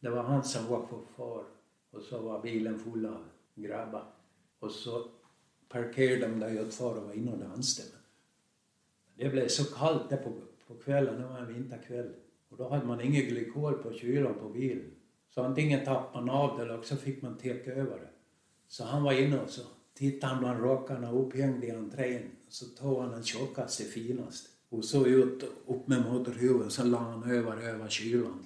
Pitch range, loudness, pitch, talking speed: 115-130 Hz, -33 LUFS, 125 Hz, 195 wpm